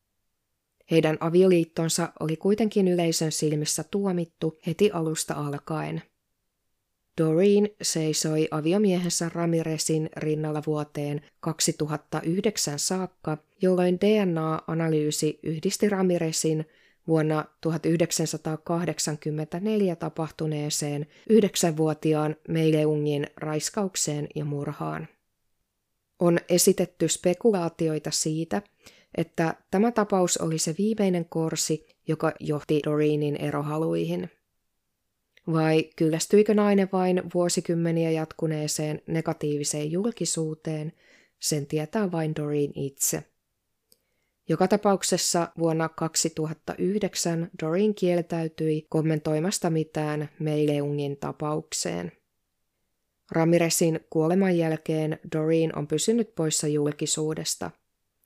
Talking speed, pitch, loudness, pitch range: 80 wpm, 160 Hz, -26 LUFS, 150-175 Hz